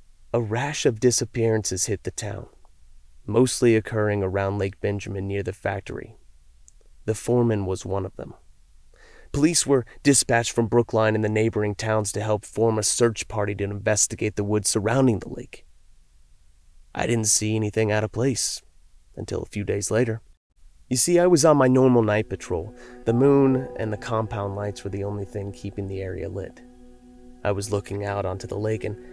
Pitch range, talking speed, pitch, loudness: 100-120 Hz, 175 wpm, 110 Hz, -23 LUFS